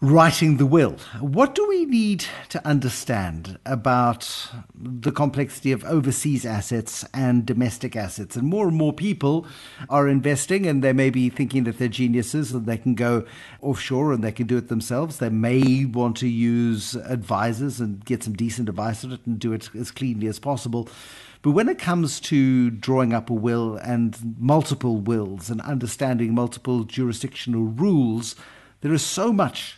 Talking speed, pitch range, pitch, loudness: 170 wpm, 115-140 Hz, 125 Hz, -23 LUFS